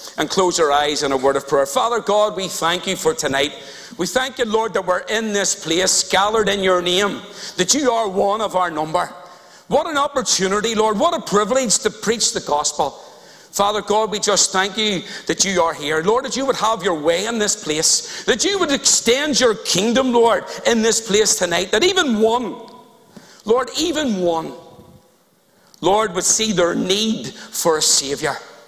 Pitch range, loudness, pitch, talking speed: 180-235 Hz, -17 LUFS, 205 Hz, 190 wpm